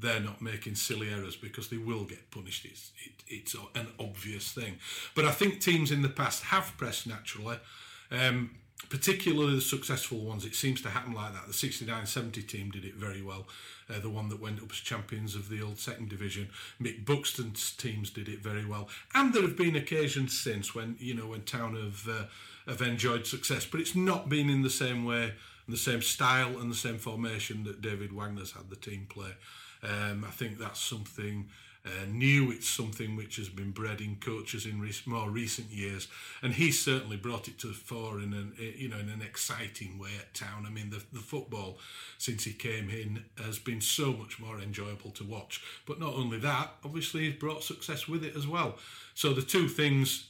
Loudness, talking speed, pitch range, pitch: -33 LUFS, 210 wpm, 105-130 Hz, 115 Hz